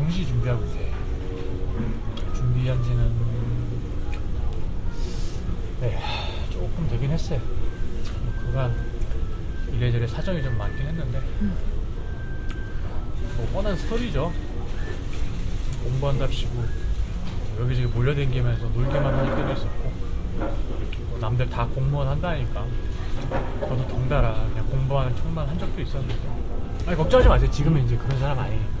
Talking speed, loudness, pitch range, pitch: 250 characters per minute, -27 LUFS, 100-130 Hz, 120 Hz